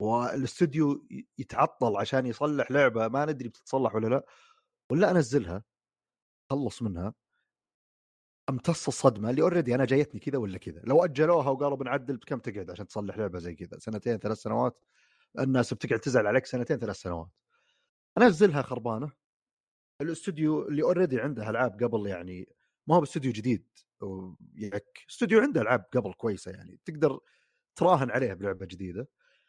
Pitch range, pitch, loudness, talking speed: 105-150 Hz, 125 Hz, -28 LUFS, 140 wpm